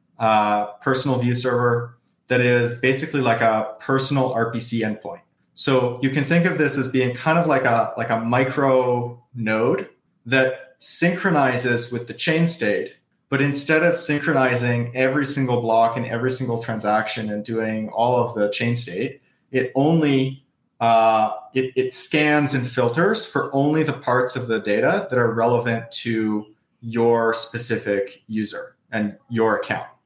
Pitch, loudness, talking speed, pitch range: 120 Hz, -20 LUFS, 155 wpm, 115-135 Hz